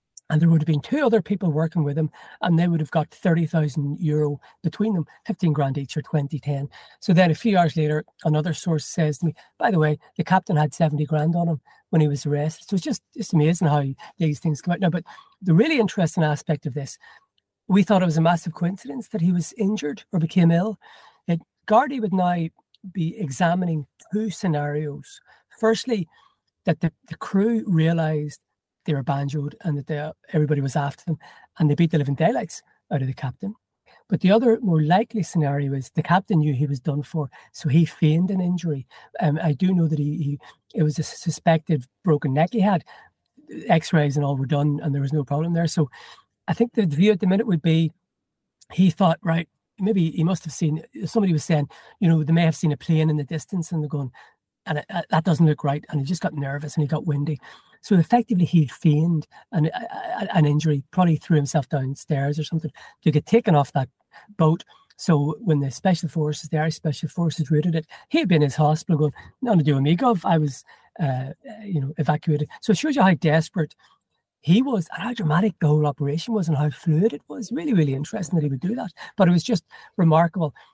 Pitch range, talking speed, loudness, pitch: 150-180 Hz, 220 wpm, -22 LUFS, 160 Hz